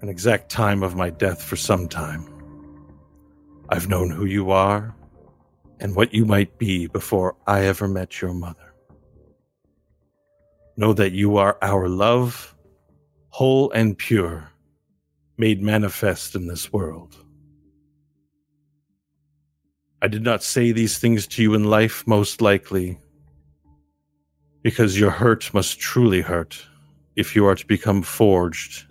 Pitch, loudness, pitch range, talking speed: 95 Hz, -20 LUFS, 75-105 Hz, 130 wpm